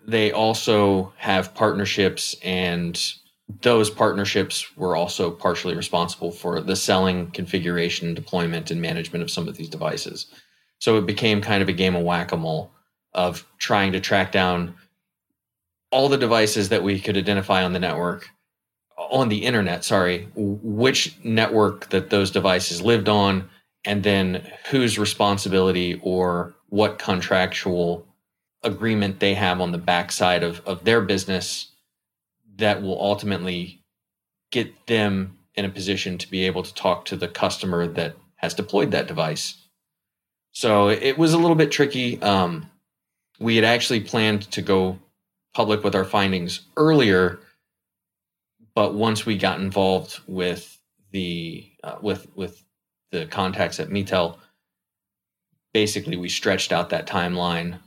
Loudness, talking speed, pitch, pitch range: -22 LUFS, 140 wpm, 95 Hz, 90-105 Hz